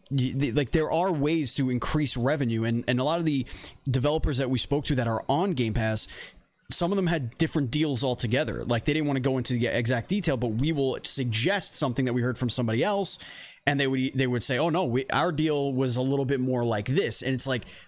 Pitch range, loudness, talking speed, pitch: 125-150 Hz, -26 LUFS, 240 wpm, 130 Hz